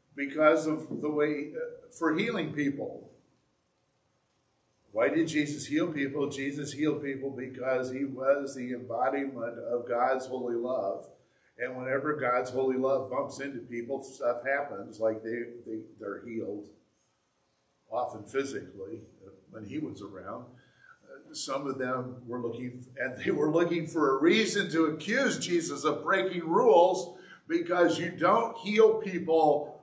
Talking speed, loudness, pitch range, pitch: 145 wpm, -30 LUFS, 125-160 Hz, 140 Hz